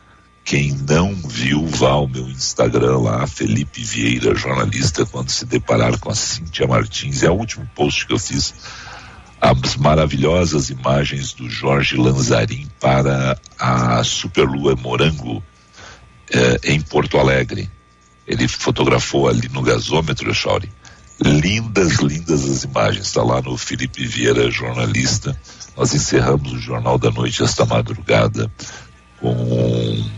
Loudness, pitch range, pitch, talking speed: -17 LUFS, 60-70 Hz, 65 Hz, 130 wpm